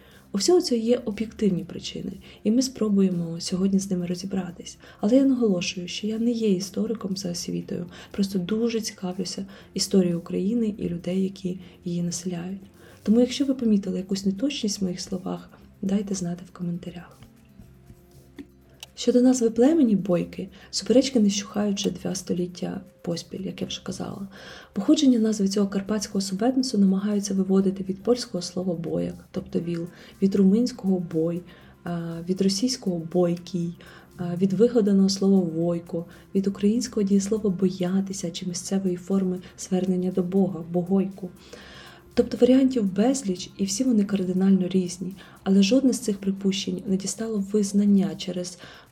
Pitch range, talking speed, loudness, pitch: 180-215 Hz, 135 wpm, -25 LUFS, 195 Hz